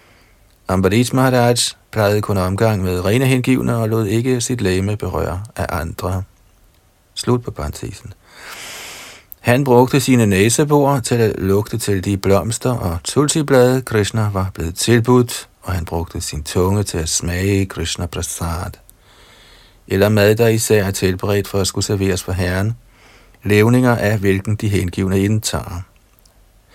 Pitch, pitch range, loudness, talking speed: 100 Hz, 95-115 Hz, -17 LUFS, 140 wpm